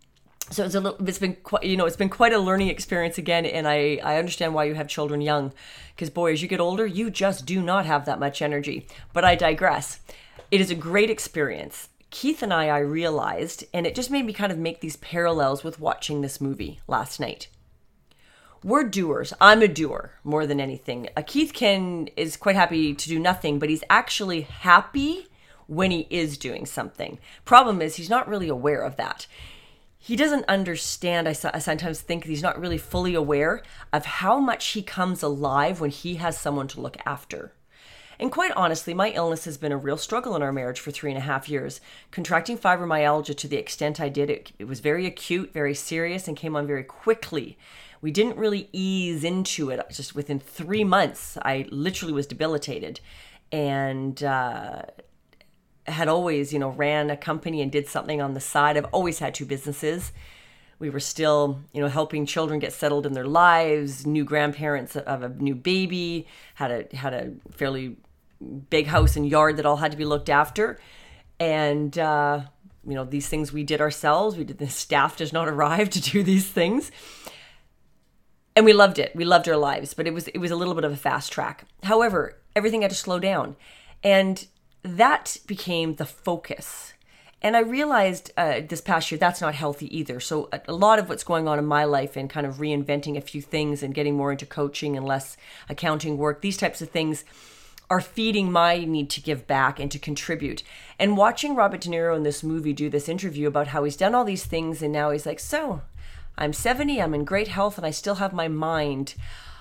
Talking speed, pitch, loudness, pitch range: 200 wpm, 160 Hz, -24 LUFS, 145-185 Hz